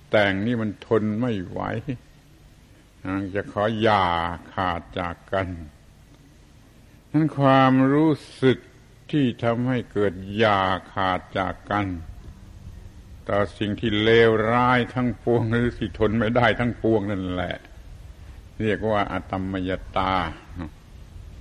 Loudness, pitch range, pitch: -23 LUFS, 95-115 Hz, 100 Hz